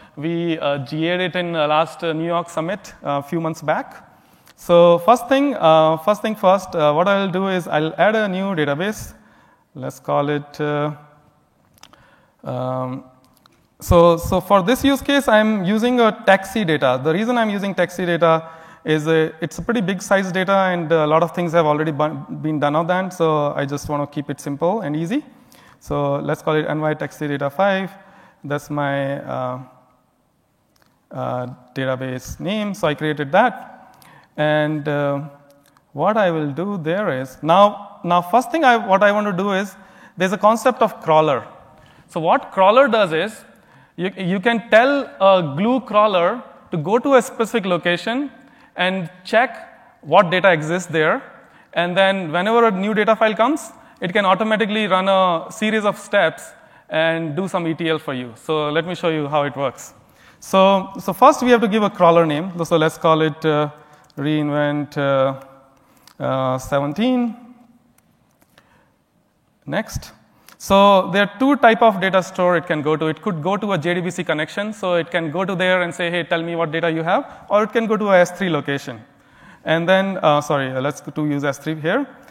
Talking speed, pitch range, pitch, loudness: 185 wpm, 150-205 Hz, 175 Hz, -18 LUFS